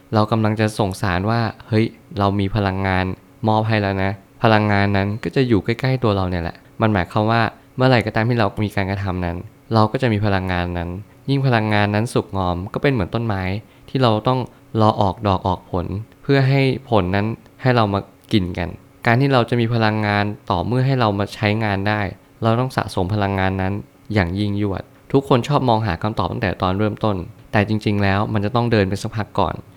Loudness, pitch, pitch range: -20 LUFS, 105 Hz, 100-115 Hz